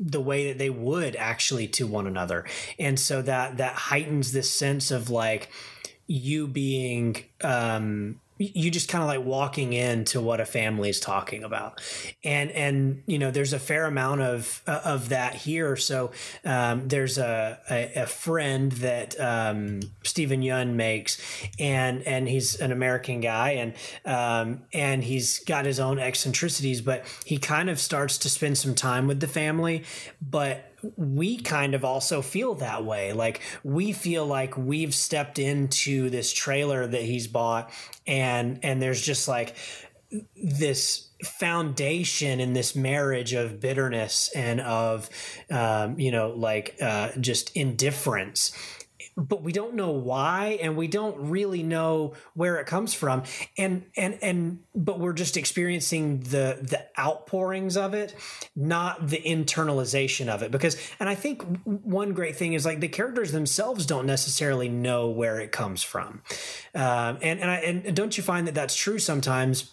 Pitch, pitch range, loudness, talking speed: 135 Hz, 125-160 Hz, -26 LUFS, 160 wpm